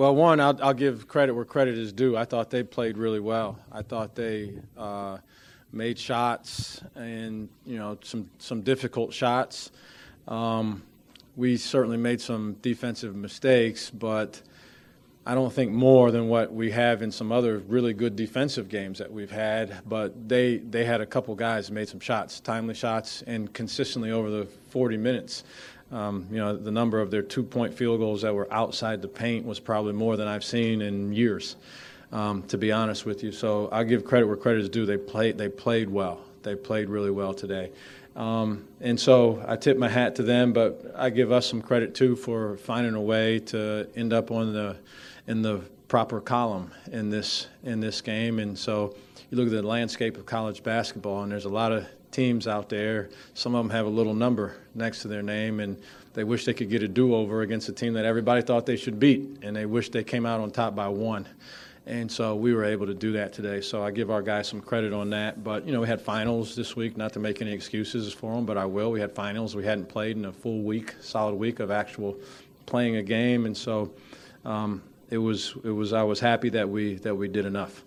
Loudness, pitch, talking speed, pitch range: -27 LUFS, 110 Hz, 215 wpm, 105-120 Hz